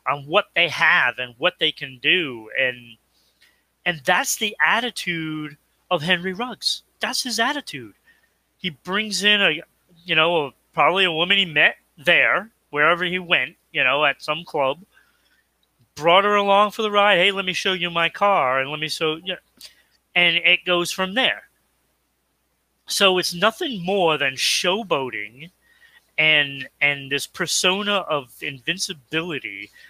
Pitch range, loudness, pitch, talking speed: 155-200 Hz, -20 LUFS, 175 Hz, 155 wpm